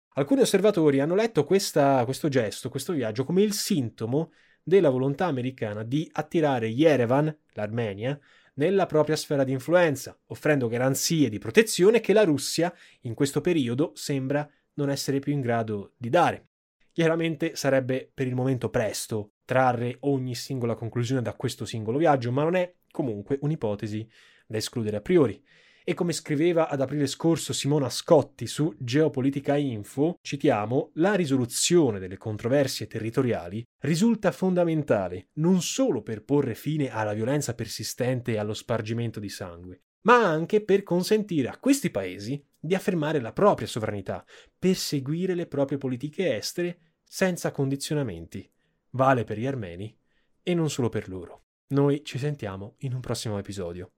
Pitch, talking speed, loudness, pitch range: 140 Hz, 145 wpm, -26 LUFS, 115-160 Hz